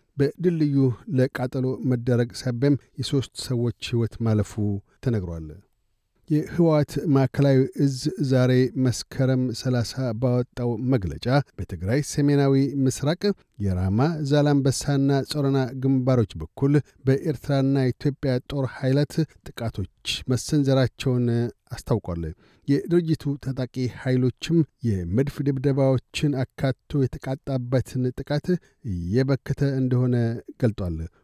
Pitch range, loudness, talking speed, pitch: 120-140 Hz, -24 LUFS, 85 wpm, 130 Hz